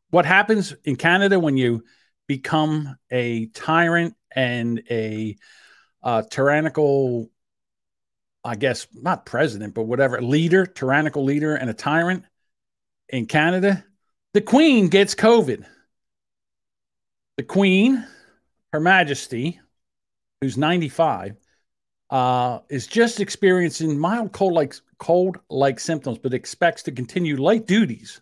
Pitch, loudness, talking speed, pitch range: 155 Hz, -20 LUFS, 110 wpm, 130-190 Hz